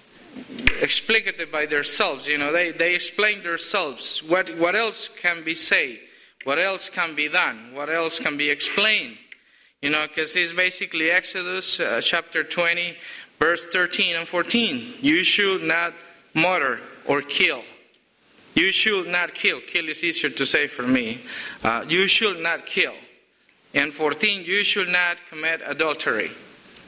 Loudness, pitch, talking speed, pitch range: -21 LUFS, 175 Hz, 150 wpm, 160-190 Hz